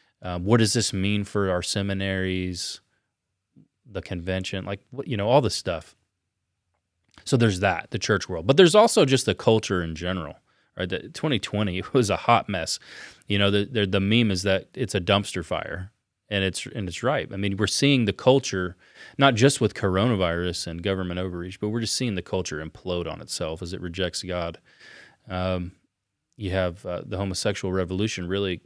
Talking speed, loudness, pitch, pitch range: 185 wpm, -24 LUFS, 95 Hz, 90-110 Hz